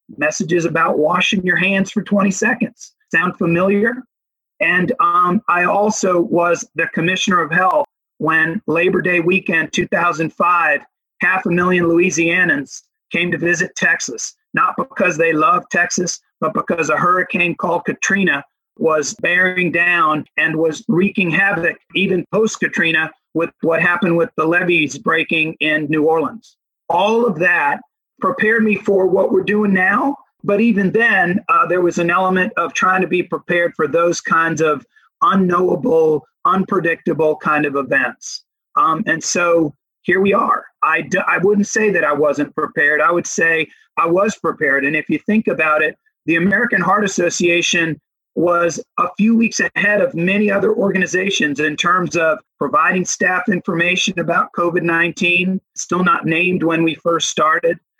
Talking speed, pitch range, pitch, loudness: 155 wpm, 165-205 Hz, 180 Hz, -16 LUFS